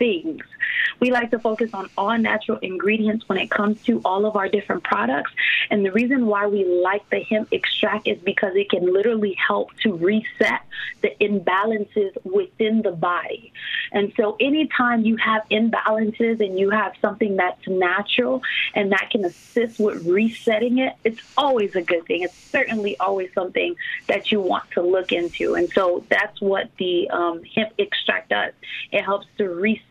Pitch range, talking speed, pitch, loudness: 195-235 Hz, 175 wpm, 215 Hz, -21 LUFS